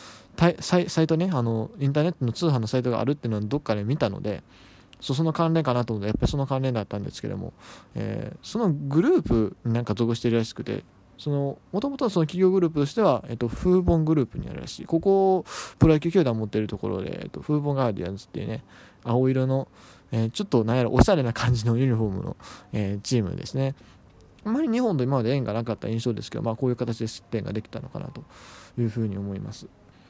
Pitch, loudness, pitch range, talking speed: 125 Hz, -25 LUFS, 110-150 Hz, 480 characters per minute